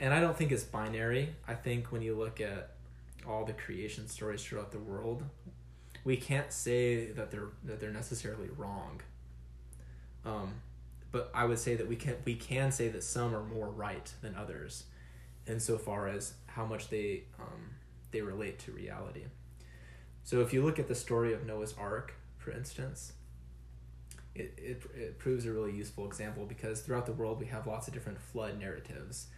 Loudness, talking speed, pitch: -38 LUFS, 180 wpm, 110 Hz